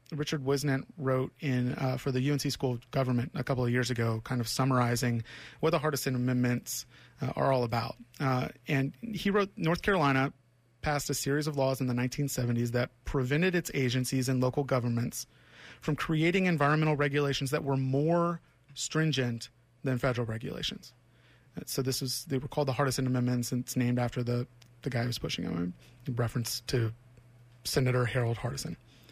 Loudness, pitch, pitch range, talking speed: -31 LUFS, 130 Hz, 120-145 Hz, 175 wpm